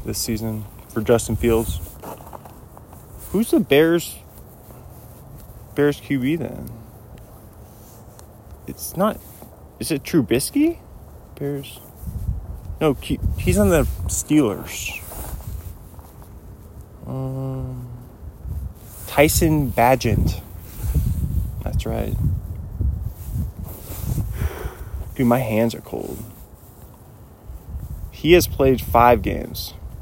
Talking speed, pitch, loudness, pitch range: 75 wpm, 110 Hz, -21 LUFS, 90-120 Hz